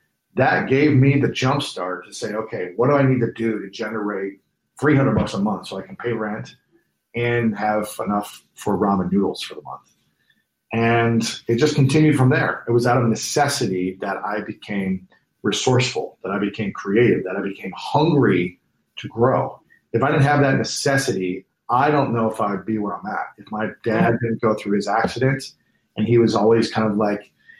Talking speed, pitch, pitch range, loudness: 195 wpm, 115 Hz, 105-130 Hz, -20 LUFS